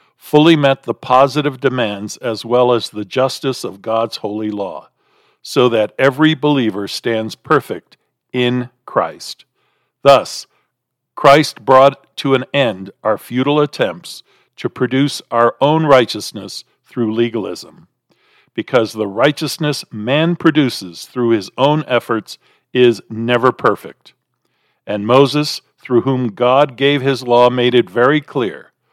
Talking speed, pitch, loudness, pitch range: 130 wpm, 125 Hz, -15 LUFS, 115-140 Hz